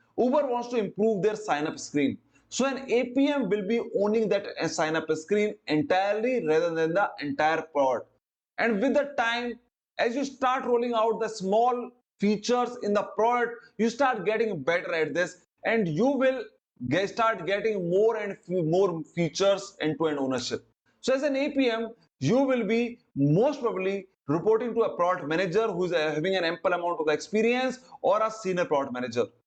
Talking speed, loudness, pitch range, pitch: 170 wpm, -27 LUFS, 175-240 Hz, 215 Hz